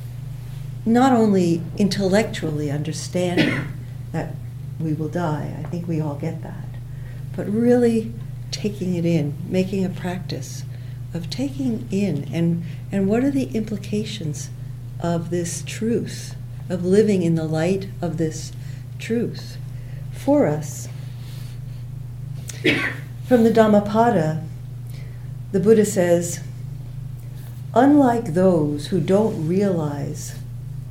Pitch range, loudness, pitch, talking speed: 125-175 Hz, -21 LUFS, 140 Hz, 105 wpm